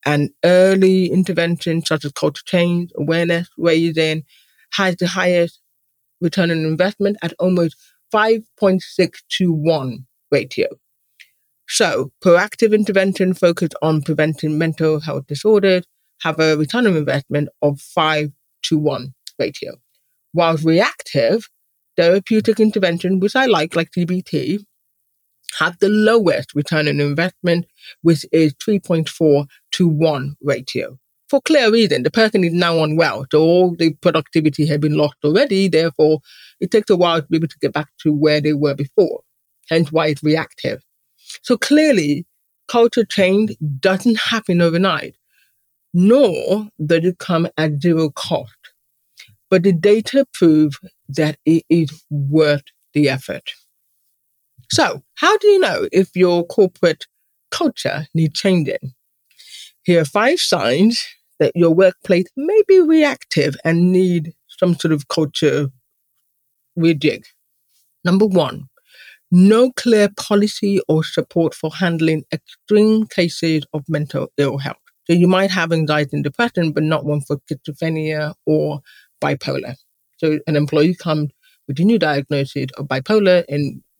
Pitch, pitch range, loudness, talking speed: 165 Hz, 150-190 Hz, -17 LUFS, 135 wpm